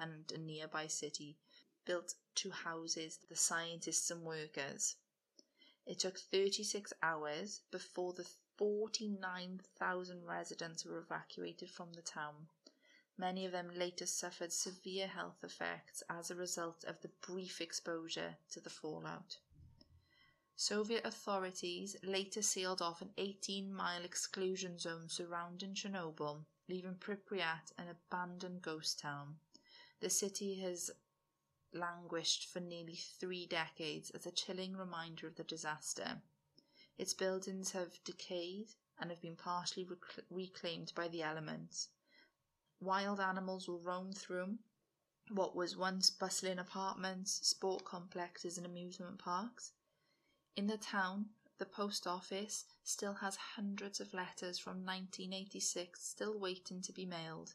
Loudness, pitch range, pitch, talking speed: -43 LUFS, 170-190 Hz, 180 Hz, 125 wpm